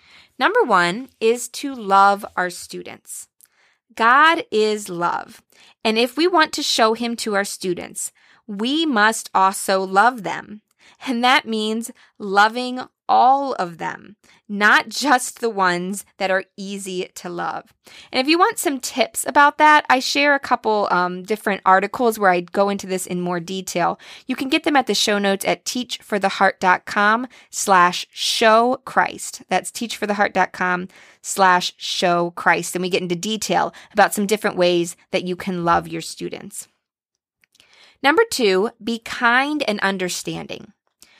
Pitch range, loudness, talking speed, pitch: 190-250 Hz, -19 LUFS, 145 wpm, 210 Hz